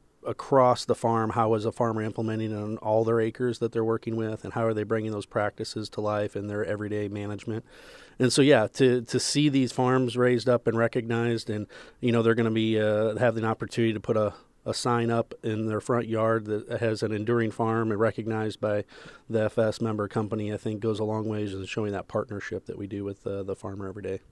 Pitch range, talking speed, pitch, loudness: 105-115 Hz, 230 wpm, 110 Hz, -27 LUFS